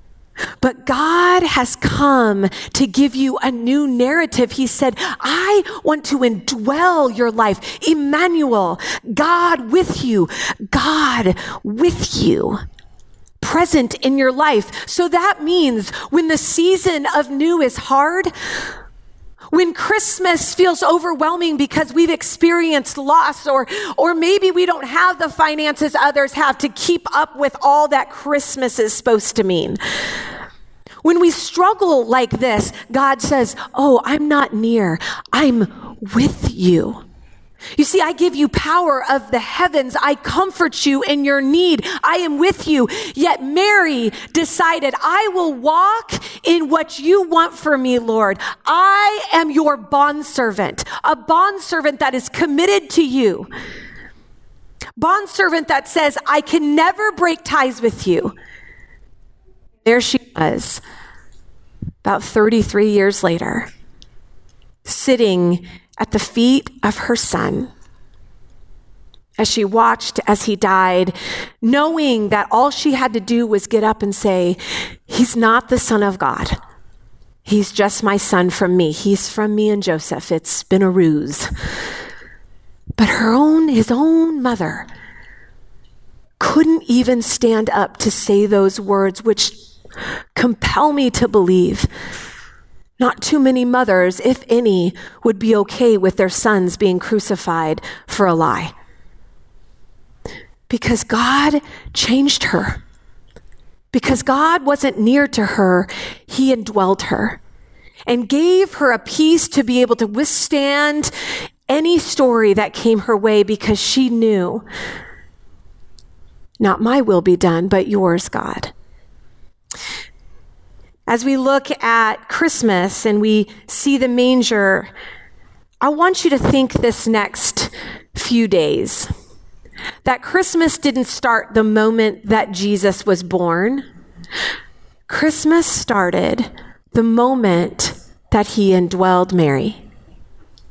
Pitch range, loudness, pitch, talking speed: 215-310 Hz, -15 LUFS, 260 Hz, 130 wpm